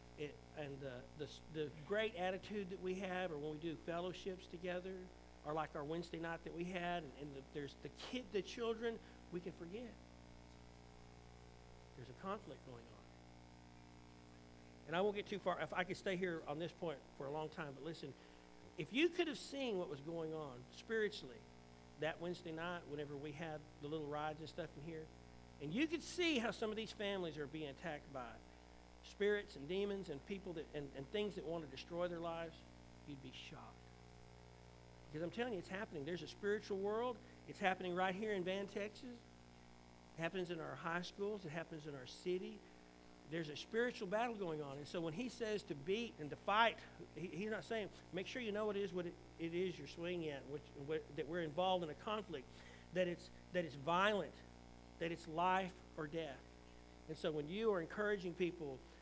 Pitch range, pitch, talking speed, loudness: 125-190 Hz, 165 Hz, 205 wpm, -45 LUFS